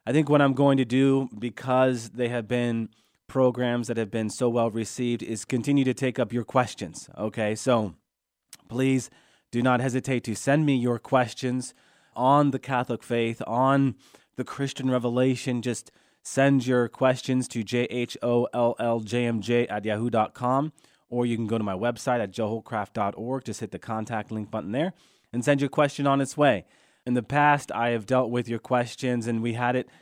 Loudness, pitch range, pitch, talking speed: -26 LUFS, 115-130 Hz, 120 Hz, 190 wpm